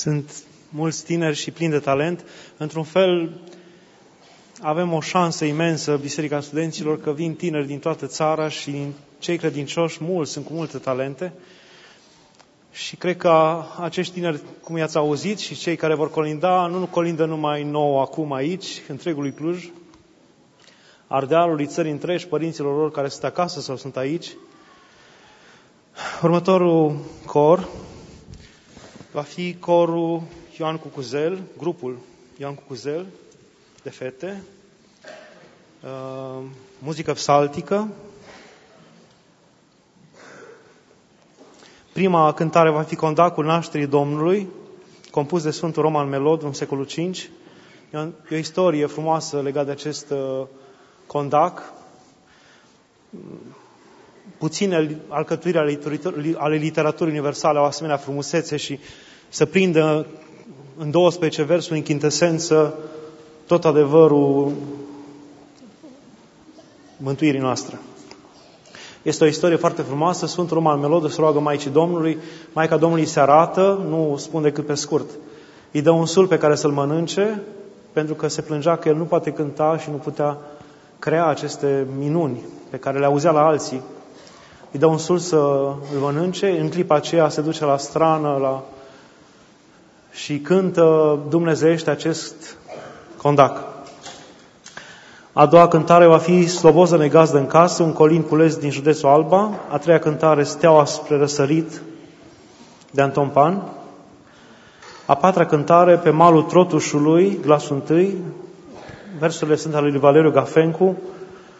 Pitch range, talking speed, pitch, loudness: 145-170 Hz, 125 wpm, 155 Hz, -19 LUFS